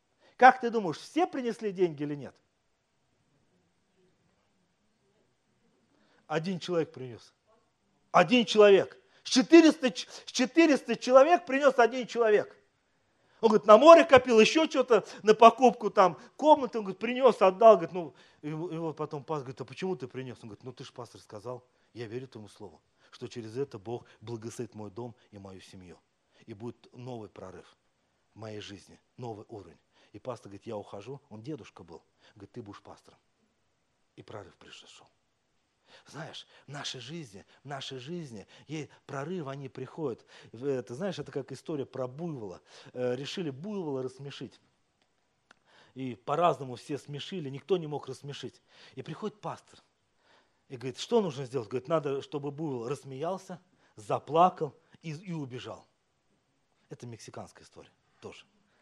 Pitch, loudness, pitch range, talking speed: 140 Hz, -26 LUFS, 125-190 Hz, 140 wpm